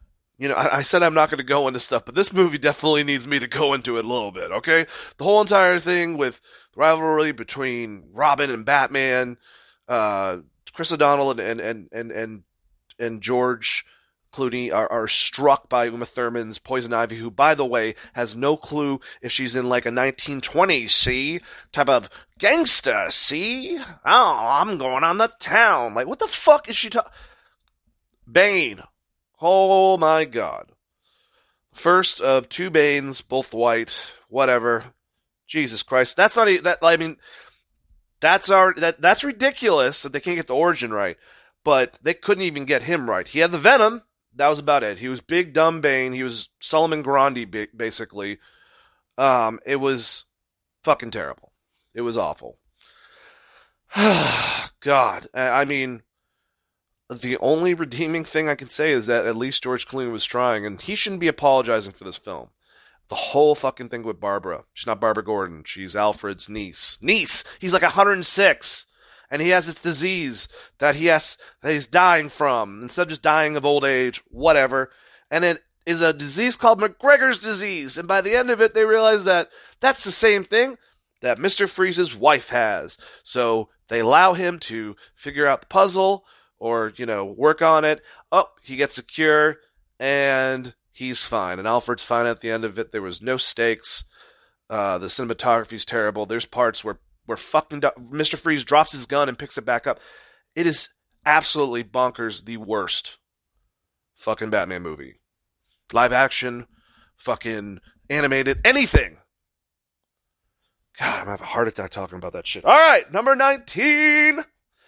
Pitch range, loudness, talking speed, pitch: 120-175 Hz, -20 LUFS, 165 wpm, 140 Hz